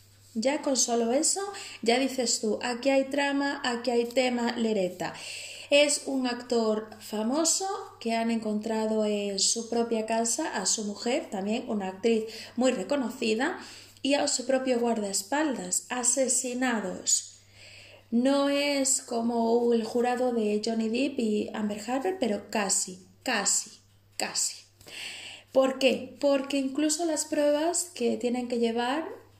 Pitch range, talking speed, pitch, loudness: 215-275 Hz, 130 wpm, 240 Hz, -27 LUFS